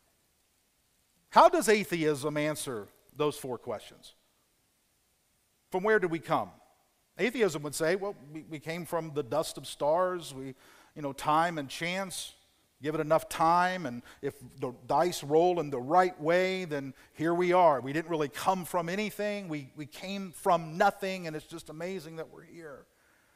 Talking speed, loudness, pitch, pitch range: 165 wpm, -30 LUFS, 160 Hz, 150-180 Hz